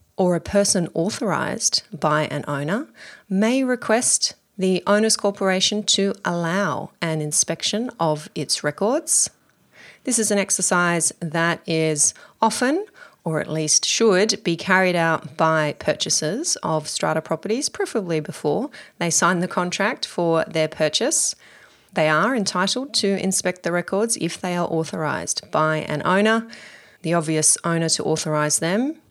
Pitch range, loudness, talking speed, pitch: 160-210 Hz, -21 LUFS, 140 wpm, 180 Hz